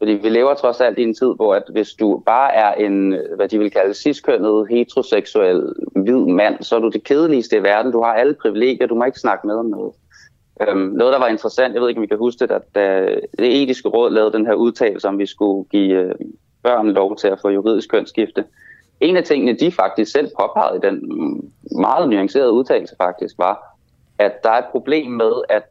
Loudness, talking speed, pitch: -17 LUFS, 215 wpm, 120 Hz